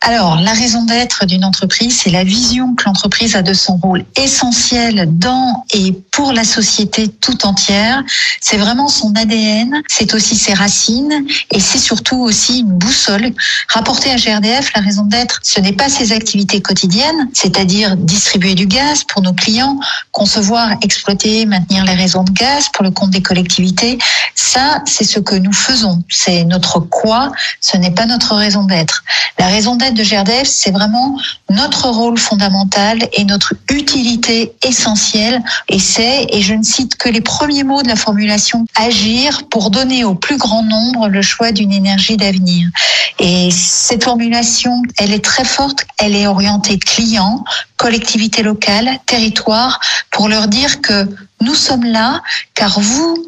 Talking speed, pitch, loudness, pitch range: 165 wpm, 220 Hz, -11 LUFS, 200-245 Hz